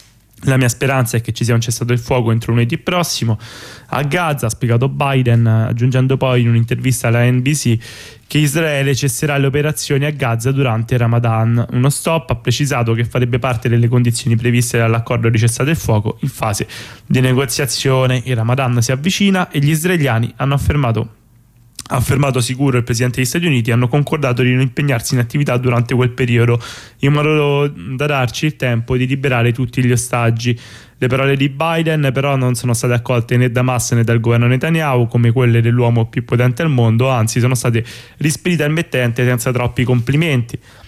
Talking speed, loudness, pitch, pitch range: 180 wpm, -15 LUFS, 125 Hz, 120-140 Hz